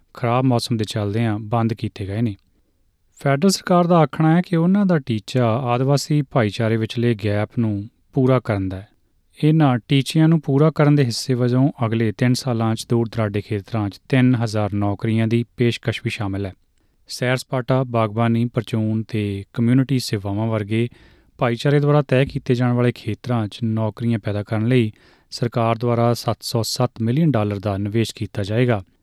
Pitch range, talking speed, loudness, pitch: 105-130 Hz, 160 wpm, -20 LUFS, 115 Hz